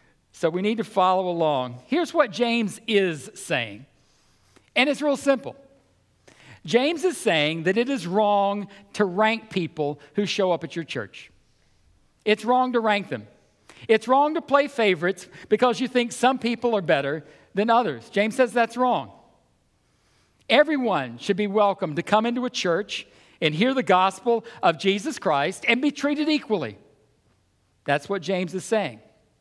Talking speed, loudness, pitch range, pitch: 160 wpm, -23 LUFS, 175-245 Hz, 210 Hz